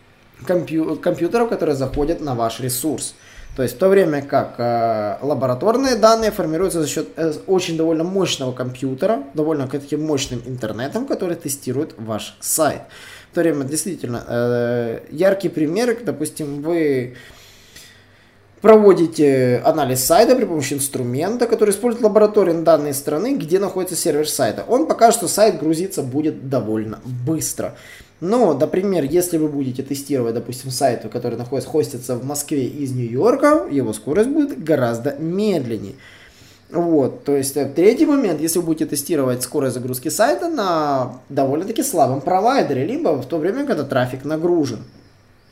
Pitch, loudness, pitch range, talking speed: 150 Hz, -19 LUFS, 125-180 Hz, 140 wpm